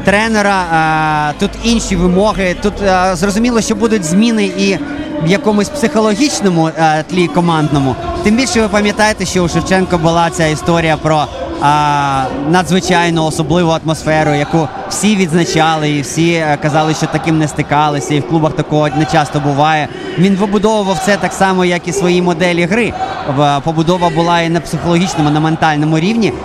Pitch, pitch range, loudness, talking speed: 175 Hz, 155-195 Hz, -12 LUFS, 145 wpm